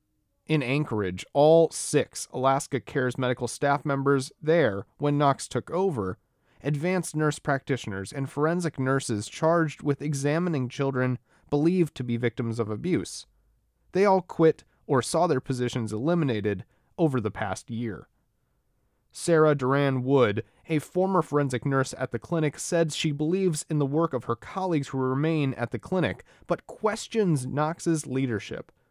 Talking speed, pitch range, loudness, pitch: 145 wpm, 125-160 Hz, -26 LUFS, 140 Hz